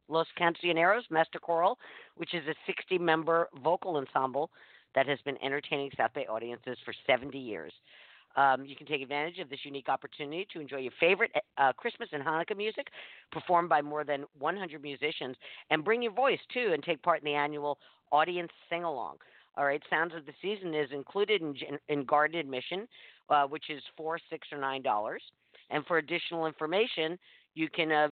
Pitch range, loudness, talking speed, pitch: 145-170 Hz, -32 LUFS, 185 wpm, 155 Hz